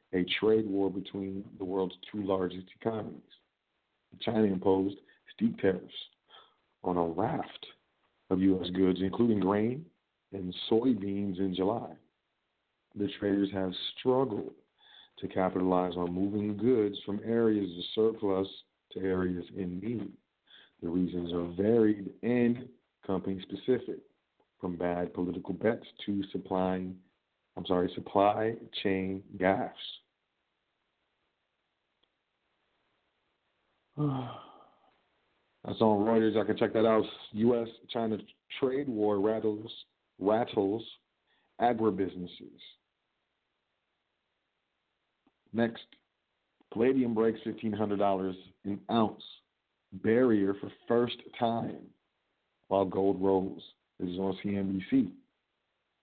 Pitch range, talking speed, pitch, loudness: 95-110 Hz, 100 wpm, 100 Hz, -31 LUFS